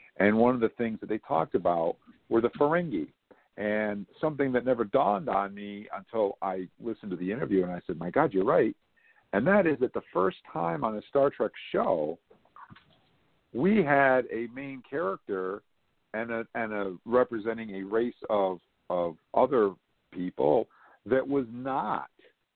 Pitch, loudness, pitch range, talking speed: 110 Hz, -29 LUFS, 95-125 Hz, 170 wpm